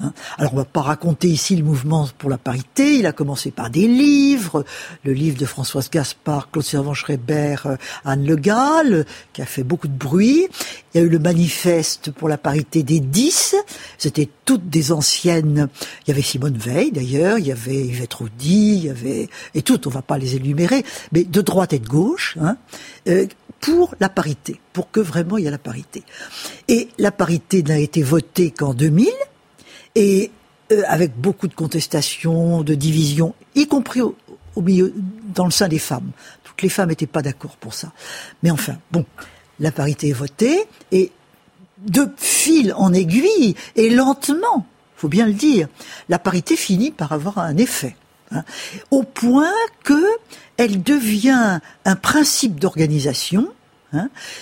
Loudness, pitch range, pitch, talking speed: -18 LUFS, 150-215 Hz, 170 Hz, 170 wpm